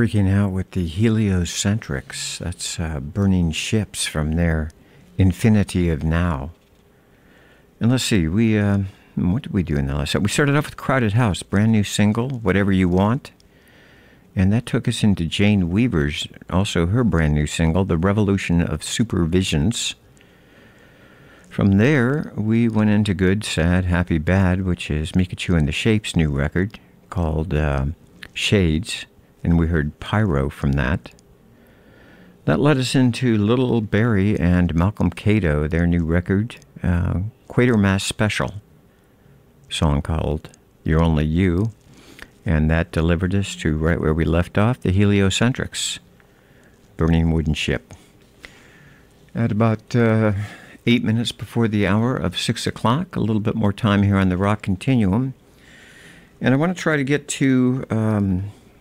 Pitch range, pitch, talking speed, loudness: 85-110 Hz, 100 Hz, 150 wpm, -20 LUFS